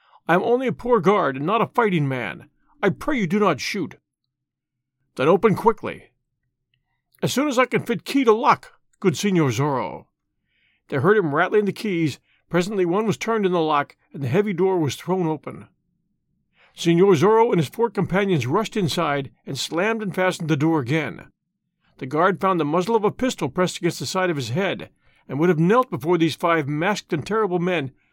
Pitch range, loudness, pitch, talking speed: 150-205 Hz, -21 LUFS, 175 Hz, 200 wpm